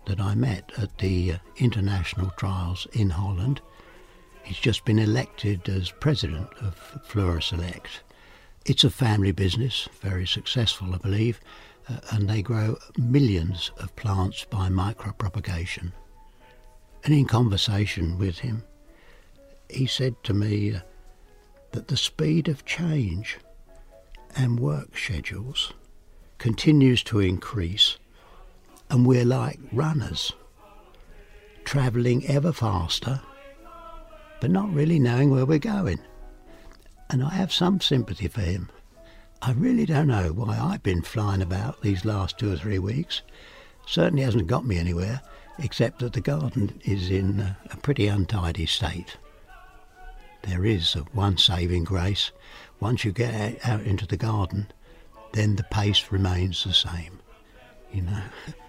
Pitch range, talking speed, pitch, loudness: 95-130 Hz, 130 wpm, 105 Hz, -25 LUFS